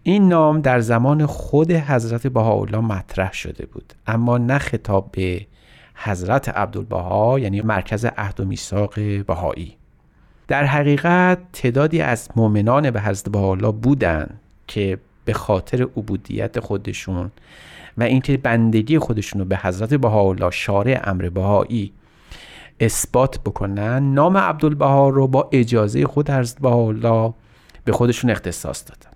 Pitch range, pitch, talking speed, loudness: 100-135 Hz, 115 Hz, 125 wpm, -19 LUFS